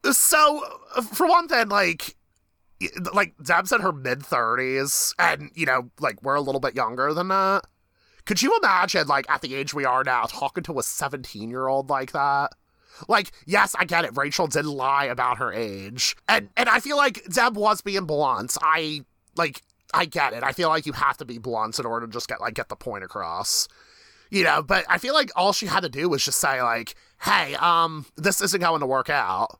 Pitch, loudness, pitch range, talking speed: 145 Hz, -23 LUFS, 130-195 Hz, 215 wpm